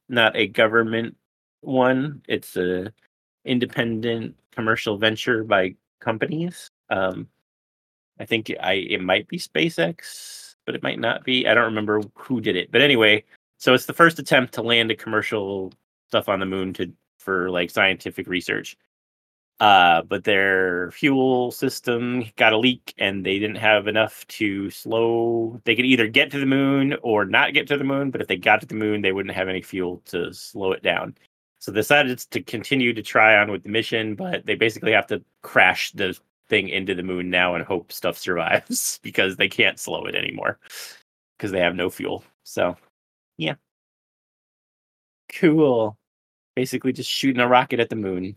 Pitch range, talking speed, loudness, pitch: 100-130 Hz, 175 wpm, -21 LUFS, 115 Hz